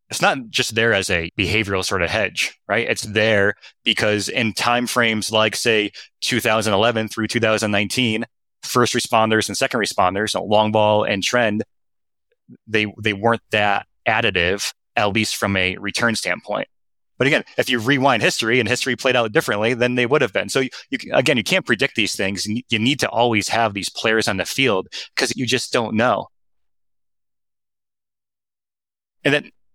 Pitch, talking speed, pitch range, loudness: 110 Hz, 175 wpm, 105-120 Hz, -19 LUFS